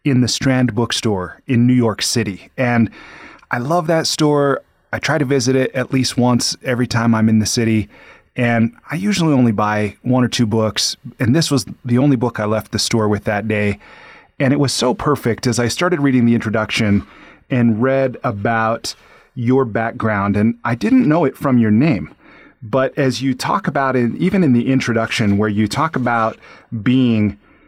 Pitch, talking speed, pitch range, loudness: 120 Hz, 190 wpm, 110-135 Hz, -17 LUFS